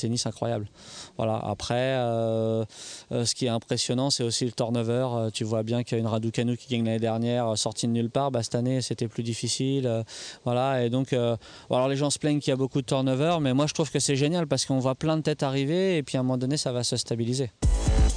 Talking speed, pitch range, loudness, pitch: 260 wpm, 115-135 Hz, -27 LUFS, 125 Hz